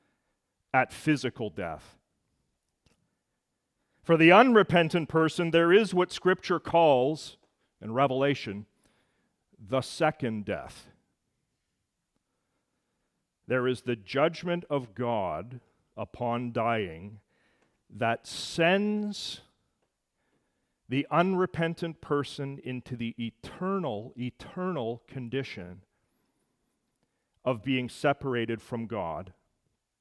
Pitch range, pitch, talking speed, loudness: 115-165 Hz, 130 Hz, 80 wpm, -28 LUFS